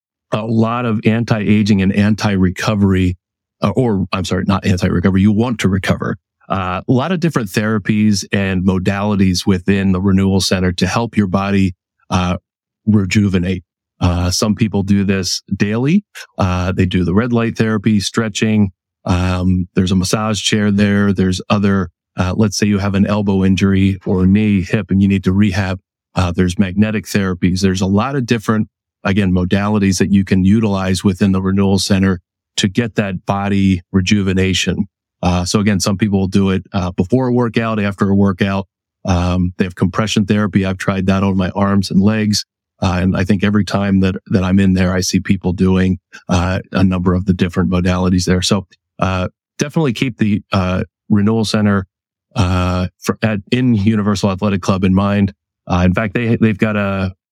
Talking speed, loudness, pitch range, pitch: 180 wpm, -15 LUFS, 95-105 Hz, 100 Hz